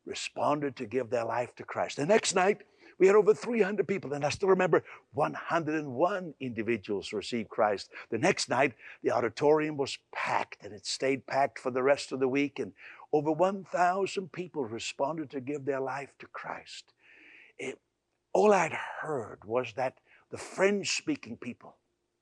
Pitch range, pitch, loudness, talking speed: 135-190 Hz, 150 Hz, -30 LUFS, 165 wpm